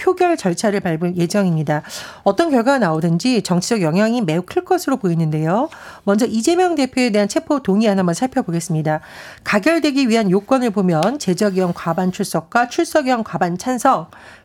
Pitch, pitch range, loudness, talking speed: 210 Hz, 175-265 Hz, -18 LUFS, 375 characters per minute